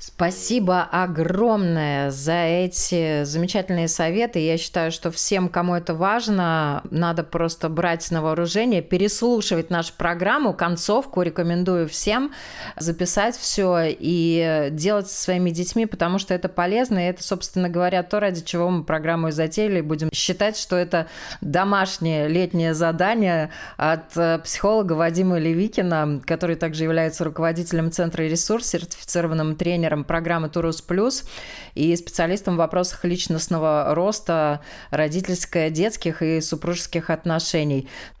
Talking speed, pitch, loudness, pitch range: 125 wpm, 170 Hz, -22 LUFS, 165-185 Hz